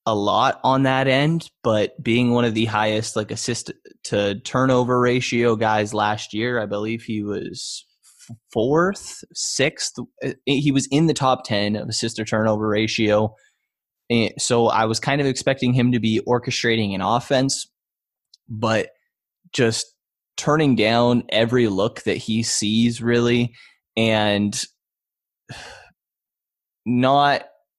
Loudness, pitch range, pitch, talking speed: -20 LUFS, 110-130 Hz, 115 Hz, 130 wpm